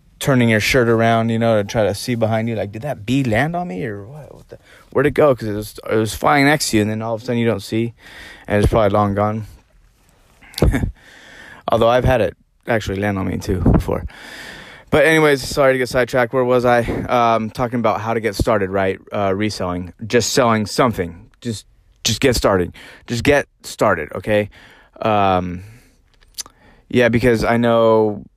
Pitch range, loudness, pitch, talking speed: 105-125 Hz, -17 LUFS, 115 Hz, 195 wpm